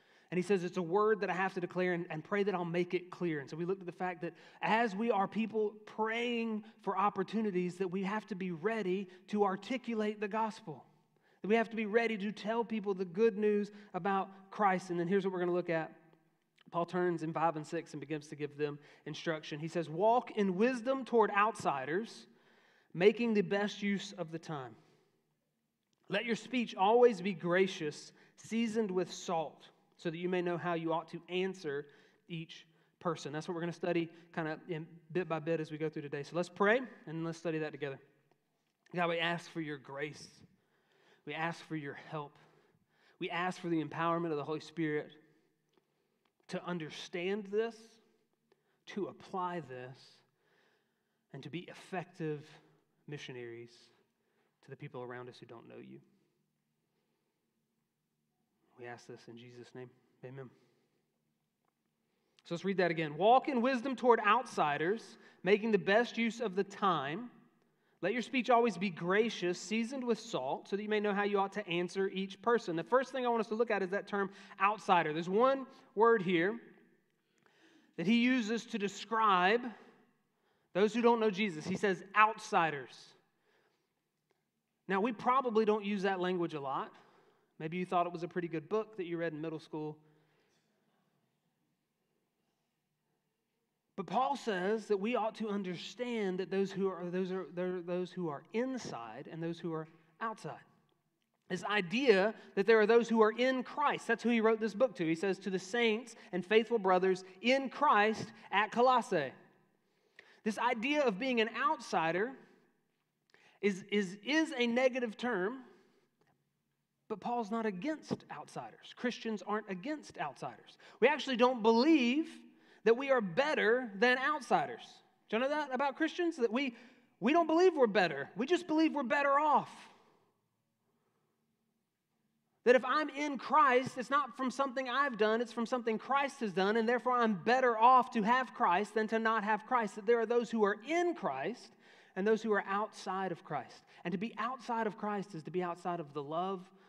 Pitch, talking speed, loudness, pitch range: 200 Hz, 180 wpm, -34 LUFS, 170-230 Hz